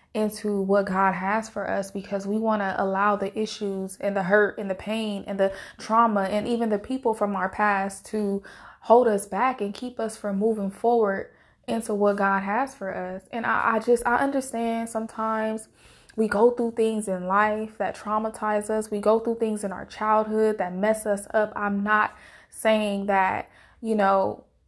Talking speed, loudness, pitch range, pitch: 190 wpm, -25 LUFS, 200-220 Hz, 210 Hz